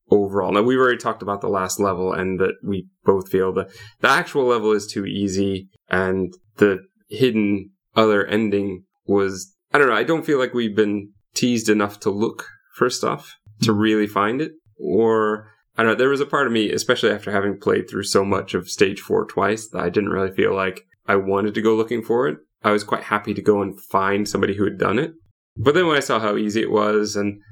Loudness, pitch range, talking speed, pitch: -20 LUFS, 95-110 Hz, 225 wpm, 105 Hz